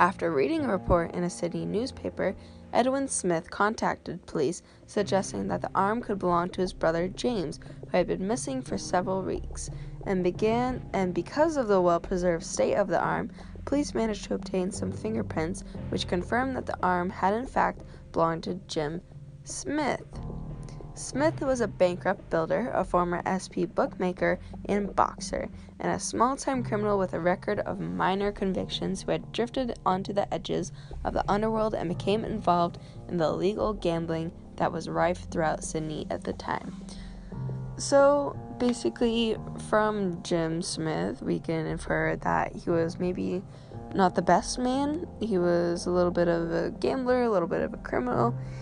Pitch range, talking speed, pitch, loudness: 170-210 Hz, 165 wpm, 185 Hz, -28 LUFS